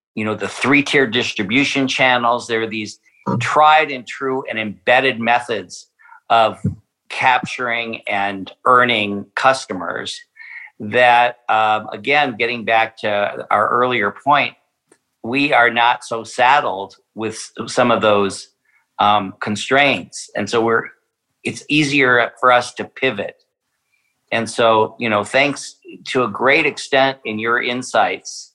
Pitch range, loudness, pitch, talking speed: 110-130 Hz, -16 LUFS, 120 Hz, 130 wpm